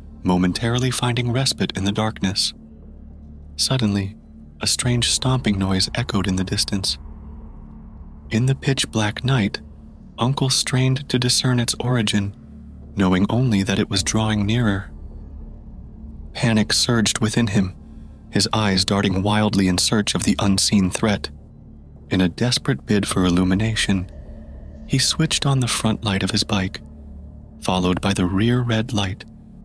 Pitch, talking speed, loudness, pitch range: 100 Hz, 140 wpm, -20 LUFS, 75-115 Hz